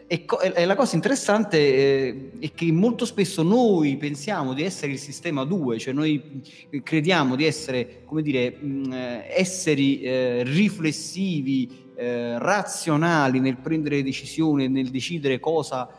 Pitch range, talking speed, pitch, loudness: 130-165 Hz, 120 wpm, 145 Hz, -23 LUFS